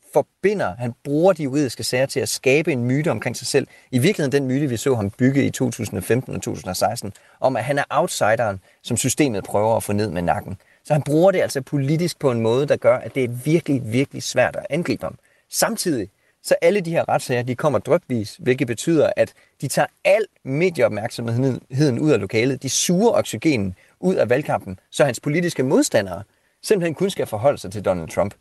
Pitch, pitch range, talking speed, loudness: 135 Hz, 120-150 Hz, 205 wpm, -21 LUFS